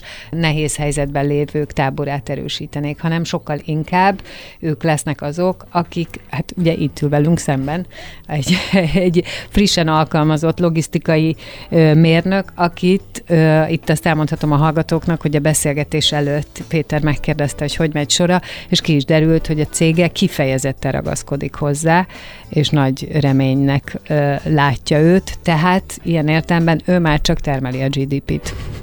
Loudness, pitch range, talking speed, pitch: -16 LUFS, 145-170 Hz, 140 wpm, 155 Hz